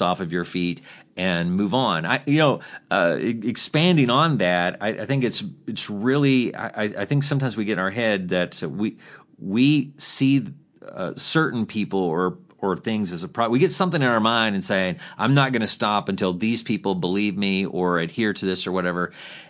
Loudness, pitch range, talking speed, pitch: -22 LUFS, 95-135 Hz, 205 wpm, 110 Hz